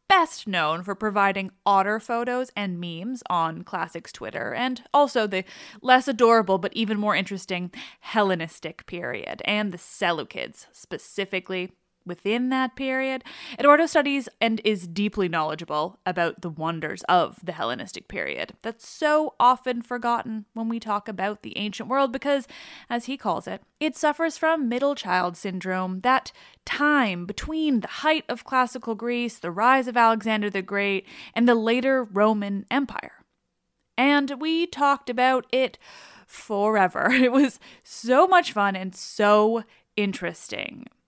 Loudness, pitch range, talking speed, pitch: -24 LUFS, 195-260 Hz, 140 wpm, 230 Hz